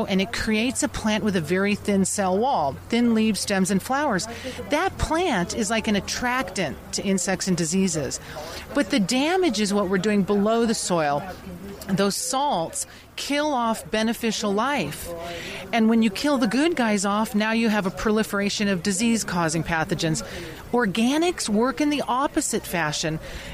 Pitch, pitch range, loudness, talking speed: 210 Hz, 190-235 Hz, -23 LUFS, 165 wpm